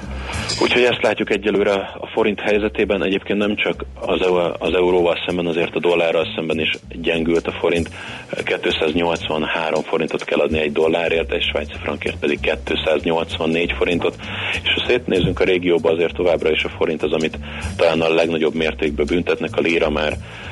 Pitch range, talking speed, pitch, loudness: 80-95 Hz, 155 wpm, 85 Hz, -19 LUFS